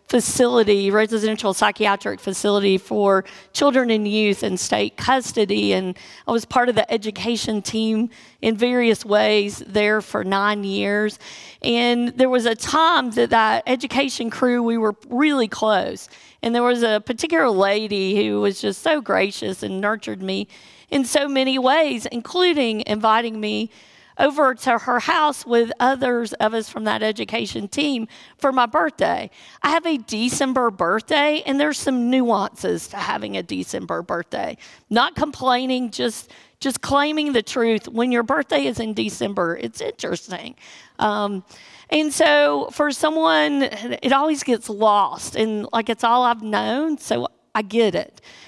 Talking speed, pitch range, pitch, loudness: 150 wpm, 210-265 Hz, 230 Hz, -20 LUFS